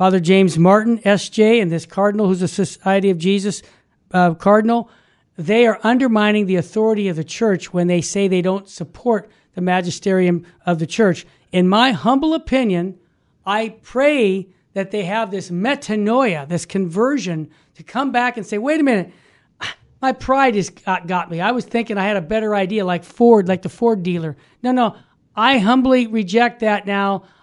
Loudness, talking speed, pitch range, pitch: -17 LUFS, 175 wpm, 180-230 Hz, 200 Hz